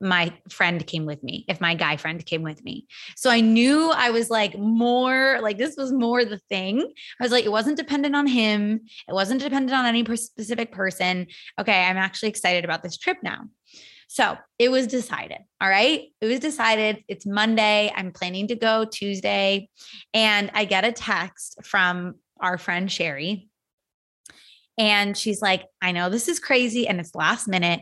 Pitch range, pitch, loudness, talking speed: 185-235 Hz, 210 Hz, -22 LUFS, 185 wpm